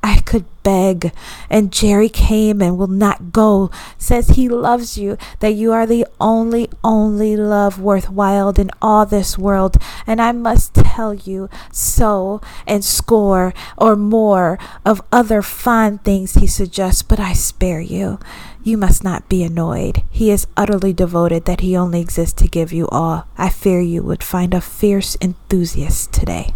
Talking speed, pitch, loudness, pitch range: 165 wpm, 200 Hz, -16 LUFS, 185-215 Hz